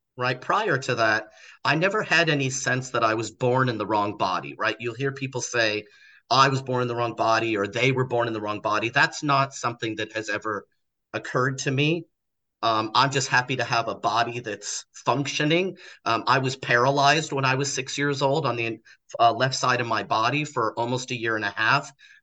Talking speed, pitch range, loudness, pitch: 220 wpm, 115-135 Hz, -24 LUFS, 125 Hz